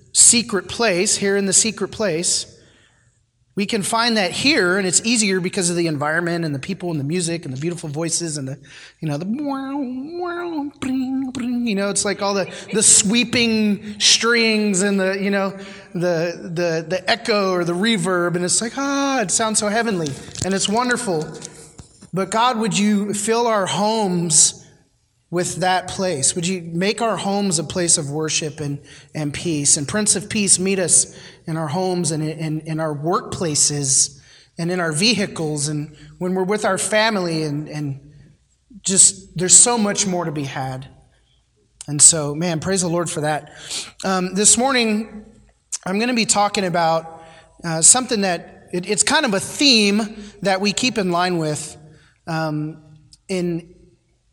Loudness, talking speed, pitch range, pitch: -18 LUFS, 170 wpm, 160-210 Hz, 185 Hz